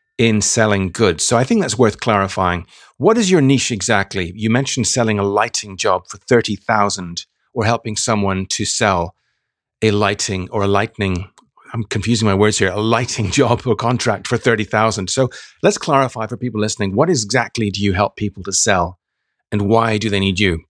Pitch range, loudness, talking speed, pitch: 100-115 Hz, -17 LUFS, 190 wpm, 105 Hz